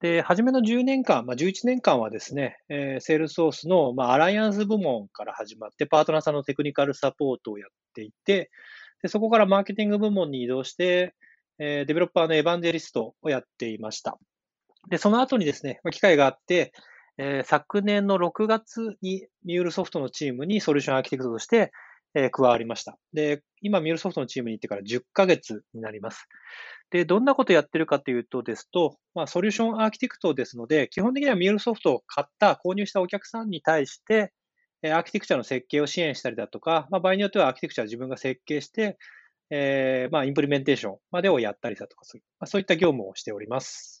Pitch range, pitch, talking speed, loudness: 135-200 Hz, 165 Hz, 470 characters per minute, -25 LUFS